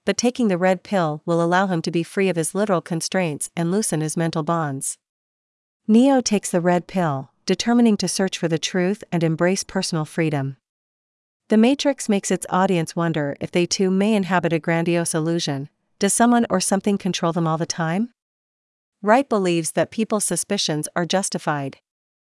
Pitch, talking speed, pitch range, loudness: 180 Hz, 175 wpm, 165-200 Hz, -21 LUFS